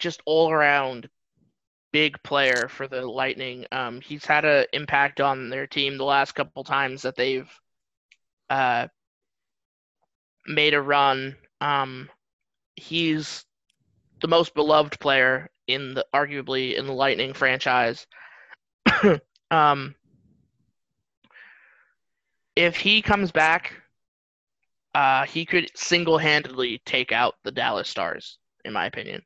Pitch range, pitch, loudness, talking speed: 130-155 Hz, 140 Hz, -23 LUFS, 115 wpm